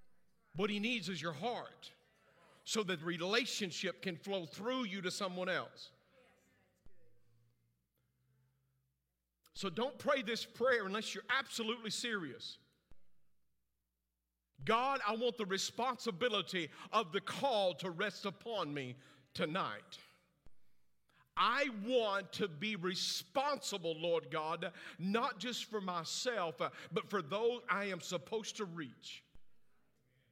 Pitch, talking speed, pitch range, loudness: 195 Hz, 115 wpm, 155-225 Hz, -38 LUFS